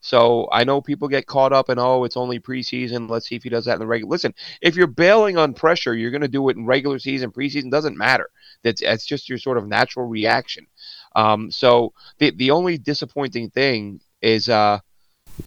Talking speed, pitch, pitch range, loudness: 215 wpm, 125 Hz, 115-140 Hz, -19 LUFS